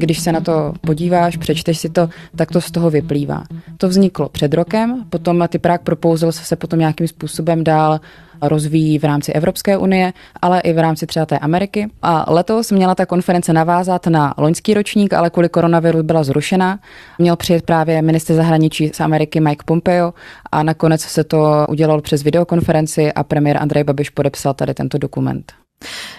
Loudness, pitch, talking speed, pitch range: -15 LUFS, 165 Hz, 170 wpm, 155-175 Hz